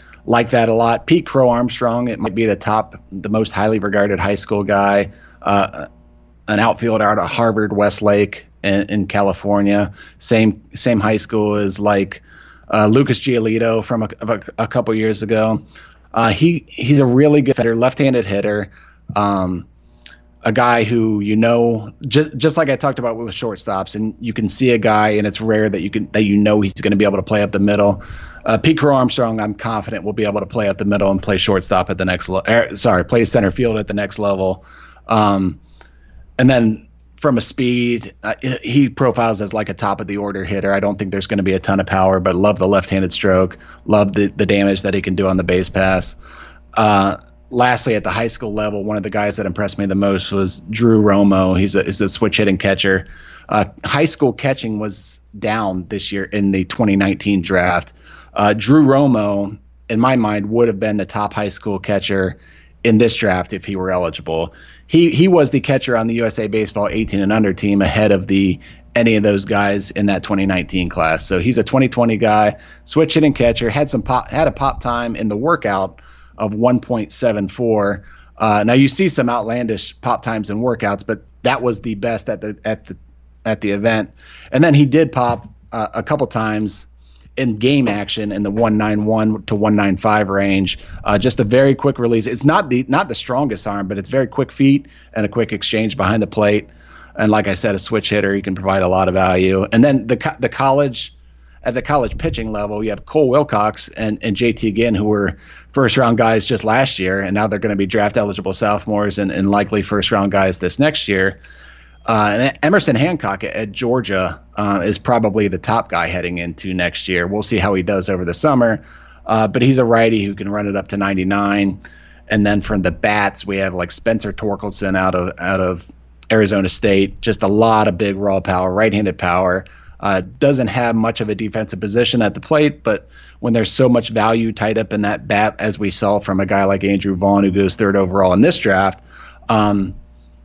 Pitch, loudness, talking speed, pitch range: 105 Hz, -16 LUFS, 210 wpm, 95-115 Hz